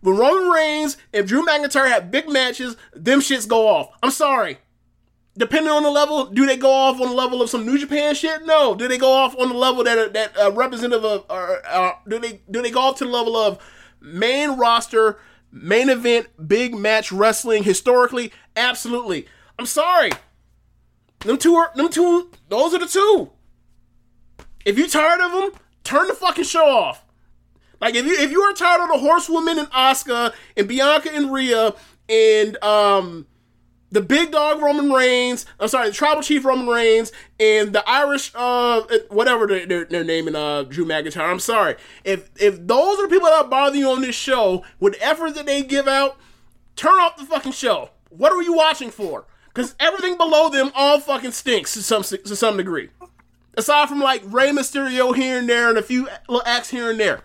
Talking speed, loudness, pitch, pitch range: 195 wpm, -18 LUFS, 255 Hz, 220-300 Hz